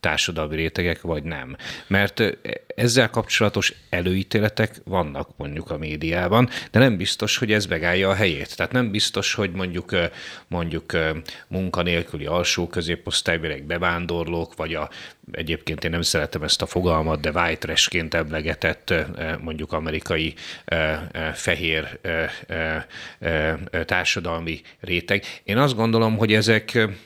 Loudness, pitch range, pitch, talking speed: -23 LUFS, 80-100 Hz, 85 Hz, 120 wpm